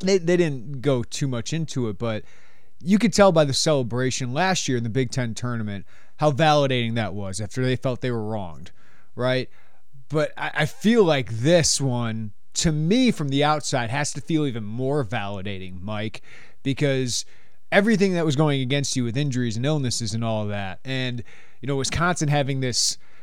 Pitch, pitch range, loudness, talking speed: 130 Hz, 115-150 Hz, -23 LUFS, 185 wpm